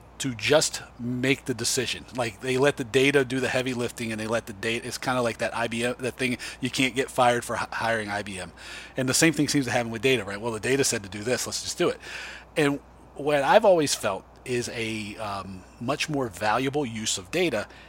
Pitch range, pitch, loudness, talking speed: 110-130 Hz, 120 Hz, -26 LUFS, 230 wpm